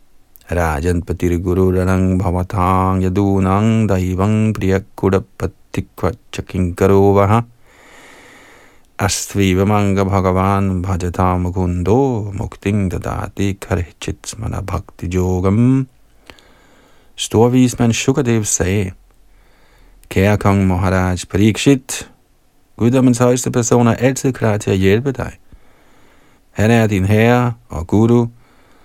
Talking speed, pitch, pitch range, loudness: 85 wpm, 100 Hz, 95-115 Hz, -16 LUFS